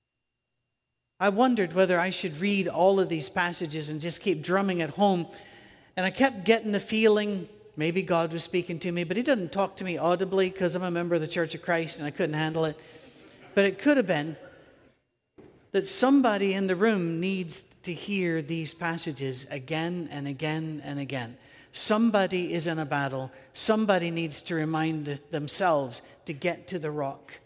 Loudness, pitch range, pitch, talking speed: -27 LUFS, 155-190 Hz, 170 Hz, 185 wpm